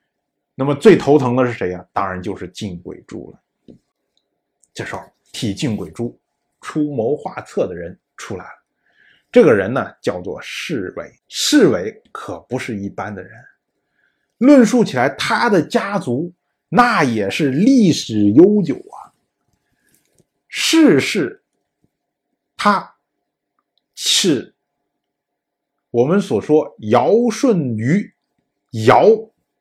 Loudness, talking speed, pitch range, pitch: -16 LUFS, 160 characters per minute, 120-185 Hz, 140 Hz